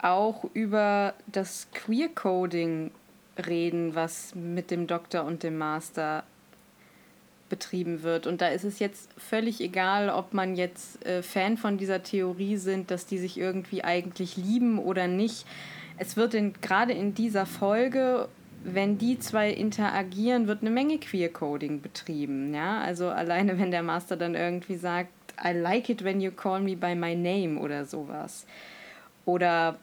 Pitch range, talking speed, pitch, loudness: 175-210 Hz, 150 wpm, 185 Hz, -29 LUFS